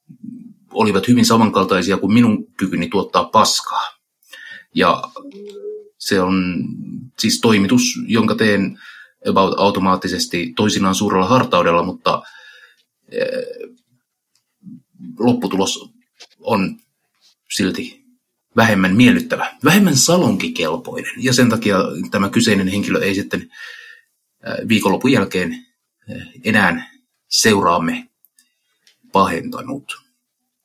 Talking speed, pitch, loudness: 80 wpm, 240 Hz, -16 LUFS